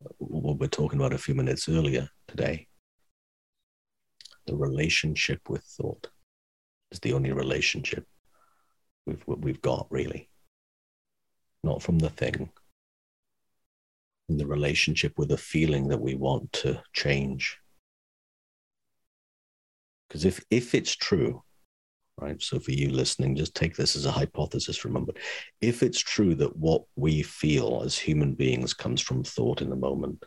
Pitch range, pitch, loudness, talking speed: 65-75 Hz, 70 Hz, -28 LUFS, 135 wpm